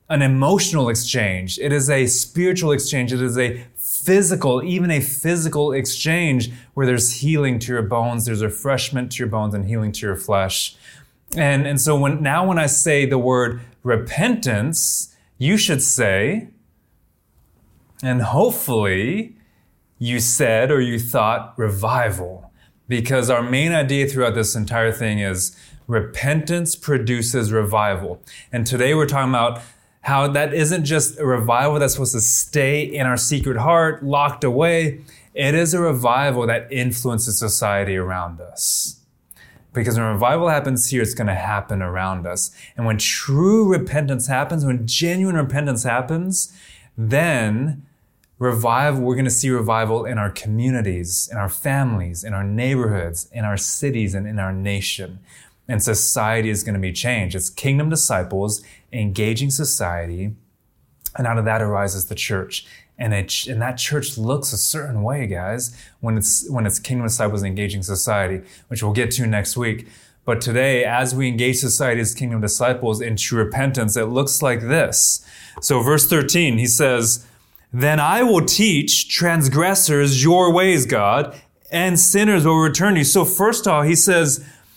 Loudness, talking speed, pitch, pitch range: -19 LUFS, 155 wpm, 125 Hz, 110-145 Hz